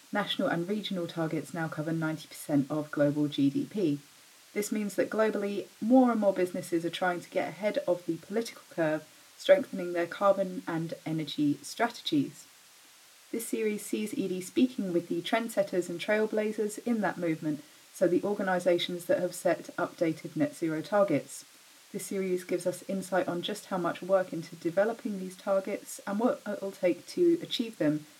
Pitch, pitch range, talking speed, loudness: 185 Hz, 170-215 Hz, 165 wpm, -31 LUFS